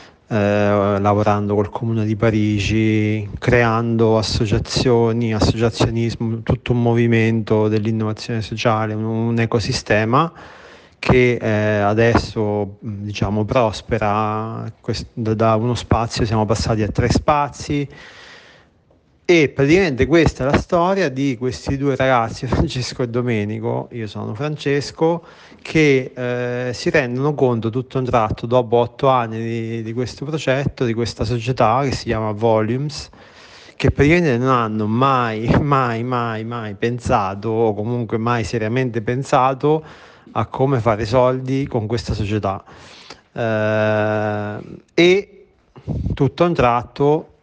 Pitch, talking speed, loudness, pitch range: 120 Hz, 115 wpm, -18 LUFS, 110-130 Hz